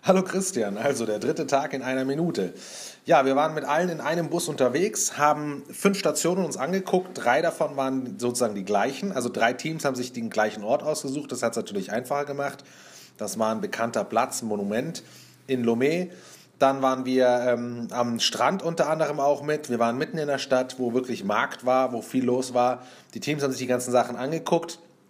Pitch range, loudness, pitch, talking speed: 125-155 Hz, -25 LUFS, 135 Hz, 205 wpm